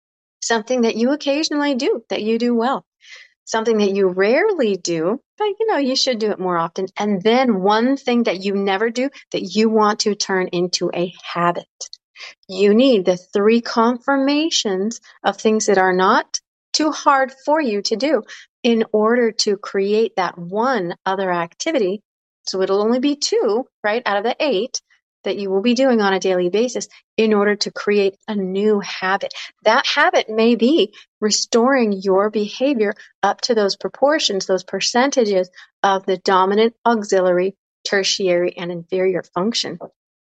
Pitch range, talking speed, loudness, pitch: 190-245 Hz, 165 wpm, -18 LUFS, 210 Hz